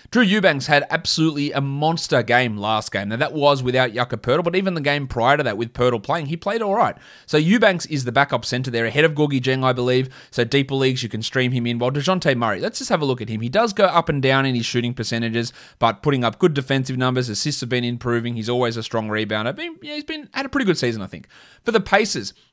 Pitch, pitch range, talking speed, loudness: 130 Hz, 120-160 Hz, 260 wpm, -20 LUFS